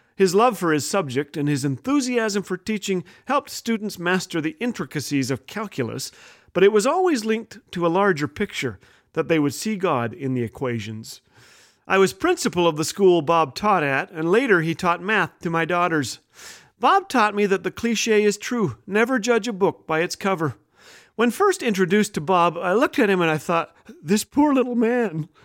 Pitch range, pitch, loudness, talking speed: 160-220 Hz, 190 Hz, -22 LUFS, 195 wpm